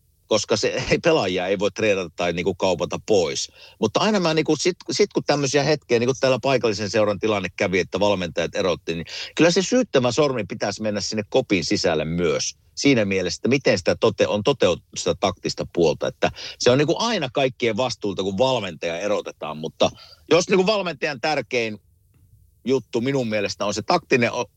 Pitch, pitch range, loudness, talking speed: 125 Hz, 105-155 Hz, -22 LUFS, 180 wpm